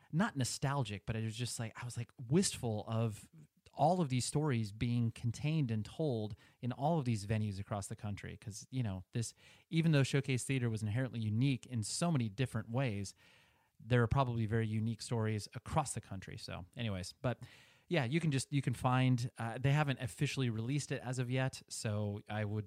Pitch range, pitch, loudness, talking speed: 110-135 Hz, 120 Hz, -37 LUFS, 200 wpm